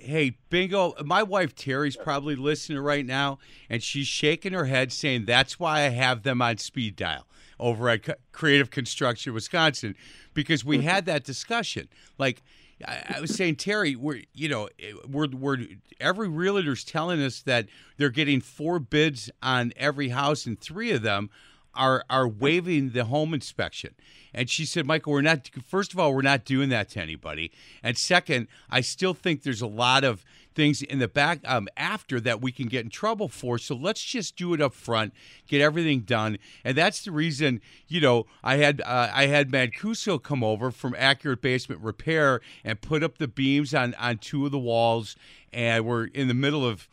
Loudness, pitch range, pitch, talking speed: -26 LUFS, 125-155 Hz, 140 Hz, 190 wpm